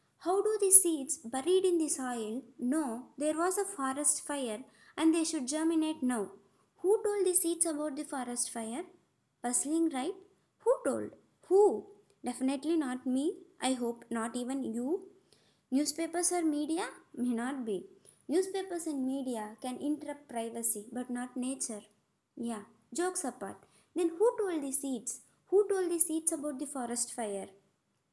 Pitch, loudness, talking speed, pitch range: 290 Hz, -32 LUFS, 150 wpm, 245-345 Hz